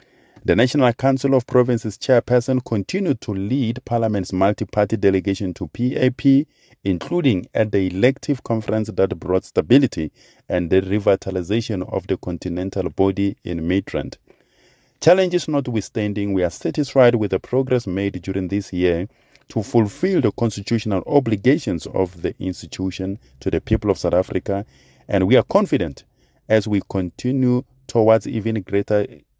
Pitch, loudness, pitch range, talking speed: 105 Hz, -20 LUFS, 95-125 Hz, 140 wpm